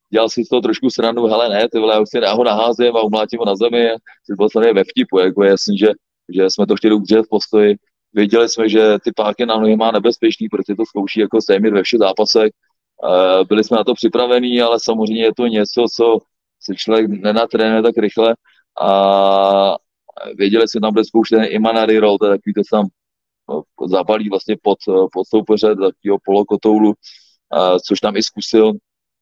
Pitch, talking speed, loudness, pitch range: 110 Hz, 180 wpm, -14 LUFS, 100-115 Hz